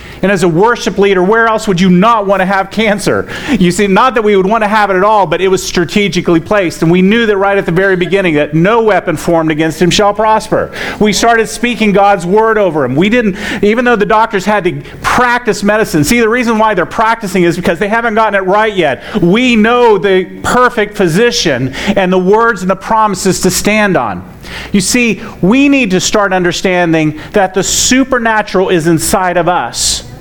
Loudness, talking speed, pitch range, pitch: -10 LUFS, 215 wpm, 180-220 Hz, 200 Hz